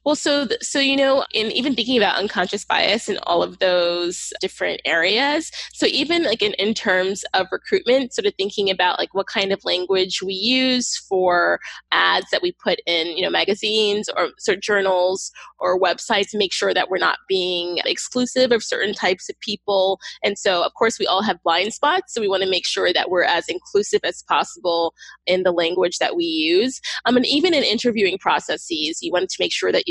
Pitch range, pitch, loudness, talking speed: 190-280 Hz, 210 Hz, -20 LUFS, 210 wpm